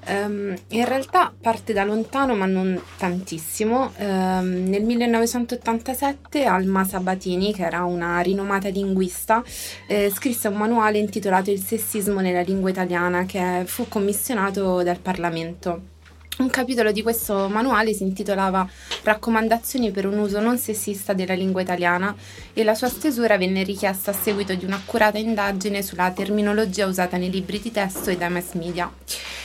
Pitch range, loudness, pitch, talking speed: 185-220 Hz, -22 LUFS, 200 Hz, 145 wpm